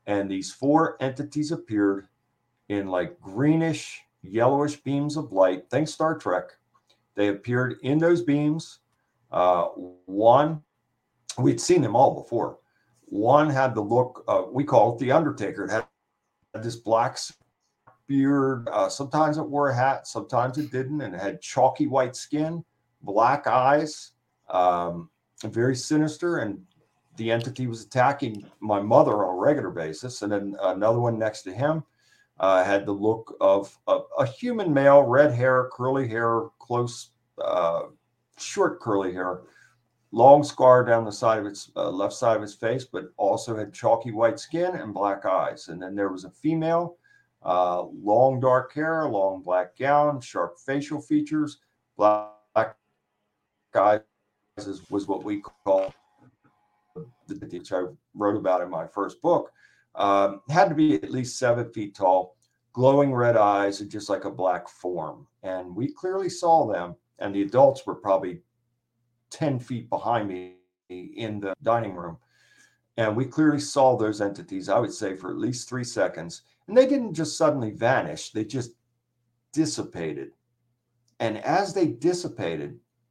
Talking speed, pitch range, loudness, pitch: 155 wpm, 100-145 Hz, -24 LUFS, 120 Hz